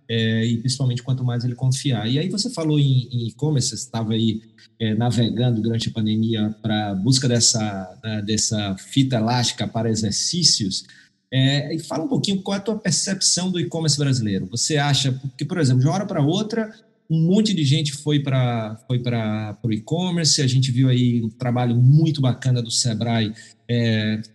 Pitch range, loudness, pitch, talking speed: 110-150 Hz, -21 LUFS, 125 Hz, 180 wpm